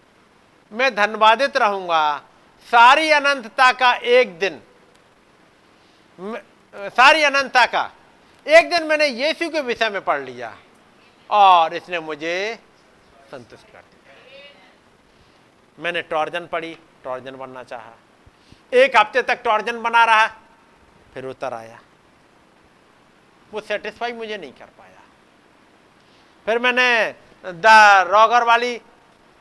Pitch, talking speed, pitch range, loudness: 220 Hz, 105 wpm, 175-250 Hz, -16 LUFS